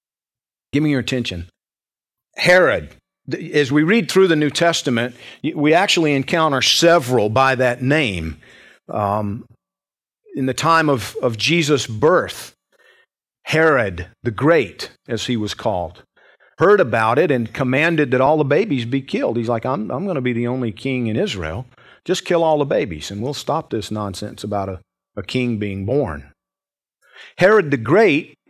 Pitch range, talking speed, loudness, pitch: 110-150 Hz, 160 wpm, -18 LUFS, 130 Hz